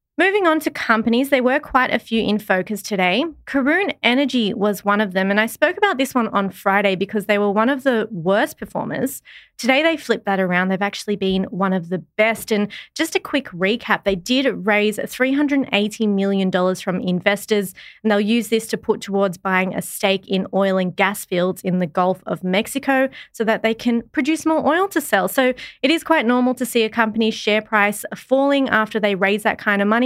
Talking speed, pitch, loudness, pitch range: 210 wpm, 215 Hz, -19 LUFS, 195-260 Hz